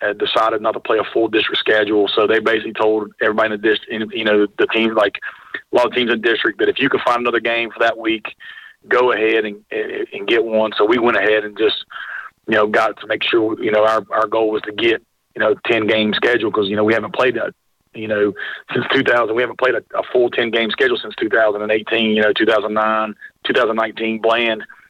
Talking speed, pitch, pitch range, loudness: 230 wpm, 110 Hz, 110-115 Hz, -17 LUFS